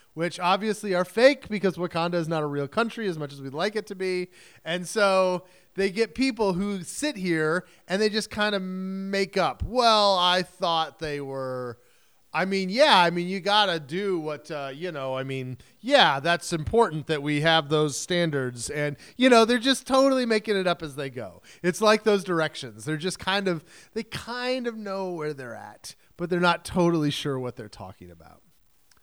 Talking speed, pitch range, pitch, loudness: 205 wpm, 150-200 Hz, 180 Hz, -25 LUFS